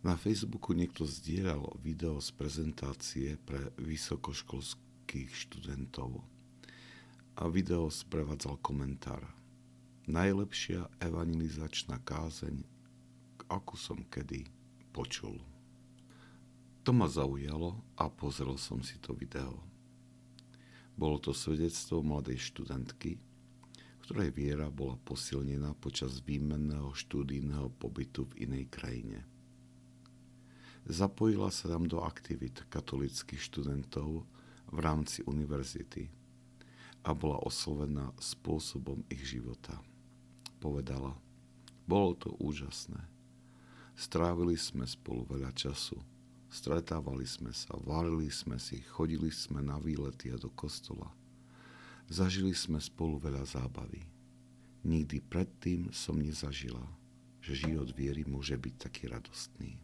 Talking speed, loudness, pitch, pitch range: 100 wpm, -38 LUFS, 75 Hz, 65-90 Hz